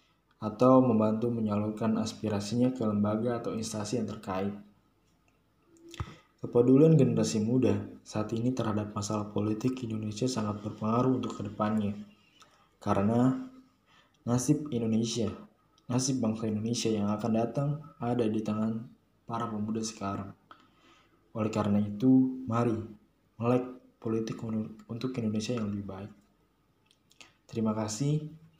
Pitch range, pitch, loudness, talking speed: 105-125 Hz, 110 Hz, -30 LUFS, 105 wpm